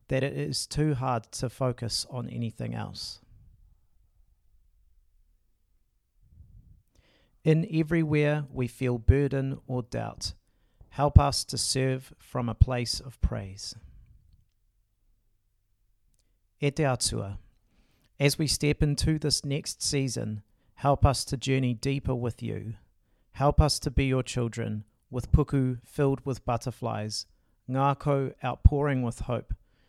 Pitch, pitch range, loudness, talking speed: 120 Hz, 105-135 Hz, -28 LUFS, 110 wpm